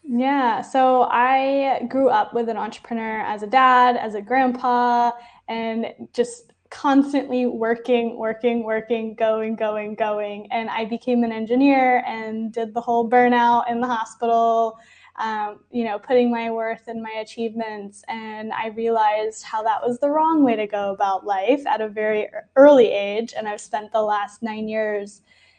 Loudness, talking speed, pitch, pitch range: -21 LUFS, 165 wpm, 230 Hz, 220-245 Hz